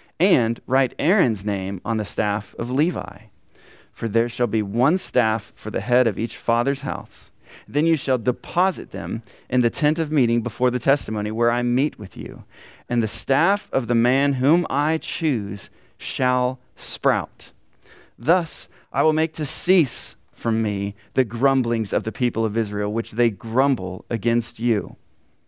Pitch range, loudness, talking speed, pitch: 115-140 Hz, -22 LUFS, 165 wpm, 120 Hz